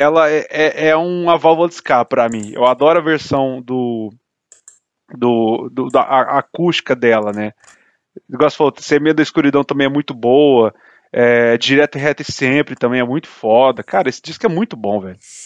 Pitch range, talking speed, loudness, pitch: 120-155 Hz, 185 wpm, -15 LUFS, 140 Hz